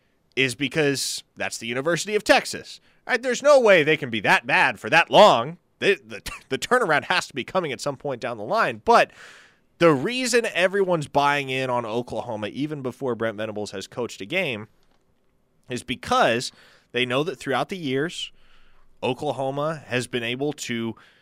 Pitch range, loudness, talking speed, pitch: 120-160 Hz, -22 LUFS, 175 wpm, 135 Hz